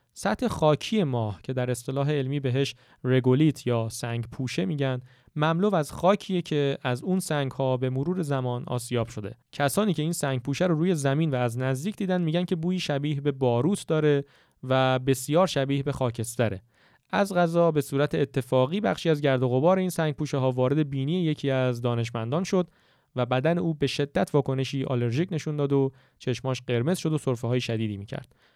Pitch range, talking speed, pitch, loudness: 125-160 Hz, 185 wpm, 140 Hz, -26 LUFS